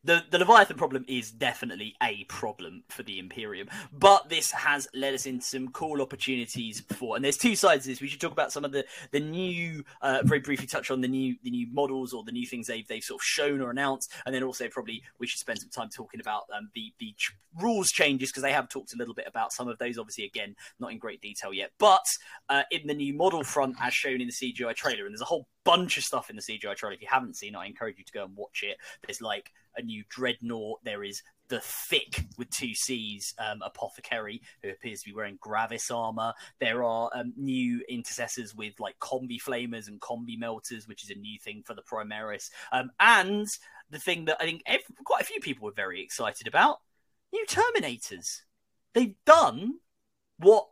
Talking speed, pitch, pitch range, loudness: 225 wpm, 130 Hz, 120-170 Hz, -28 LUFS